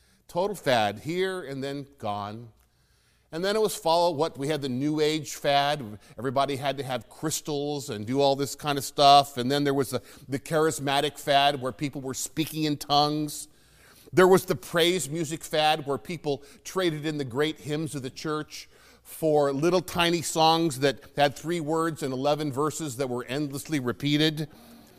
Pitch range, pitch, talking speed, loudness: 140-160 Hz, 145 Hz, 180 wpm, -26 LUFS